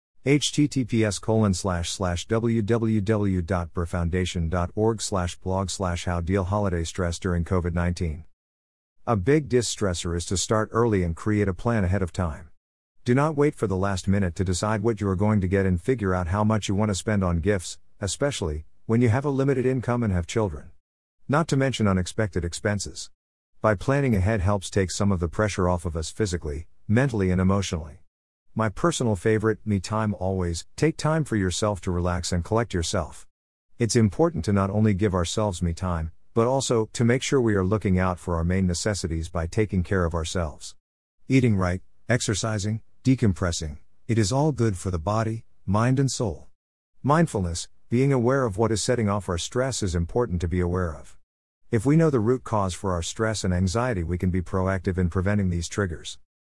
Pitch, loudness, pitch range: 100 Hz, -25 LUFS, 90-115 Hz